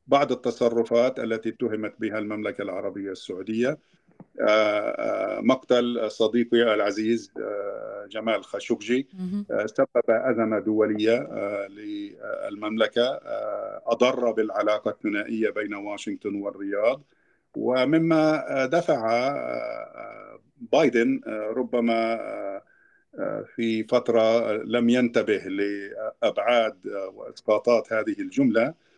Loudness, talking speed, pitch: -25 LUFS, 70 wpm, 120 Hz